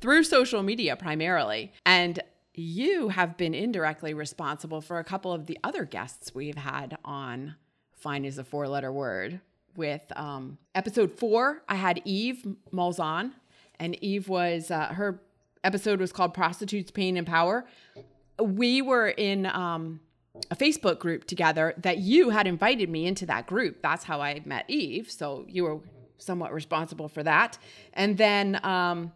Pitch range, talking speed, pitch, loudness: 155-200 Hz, 155 wpm, 175 Hz, -28 LUFS